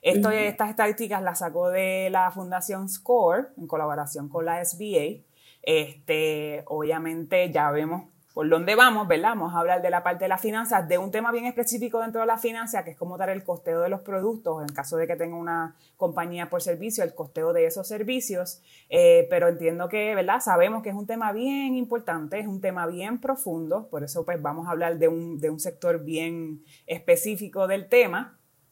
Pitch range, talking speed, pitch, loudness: 165-220 Hz, 200 wpm, 180 Hz, -25 LUFS